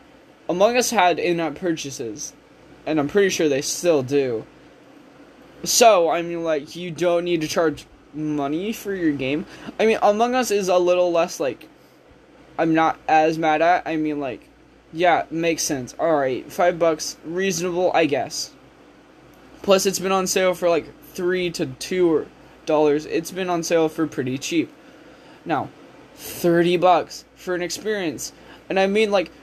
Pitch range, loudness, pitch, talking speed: 155-190 Hz, -21 LUFS, 170 Hz, 160 wpm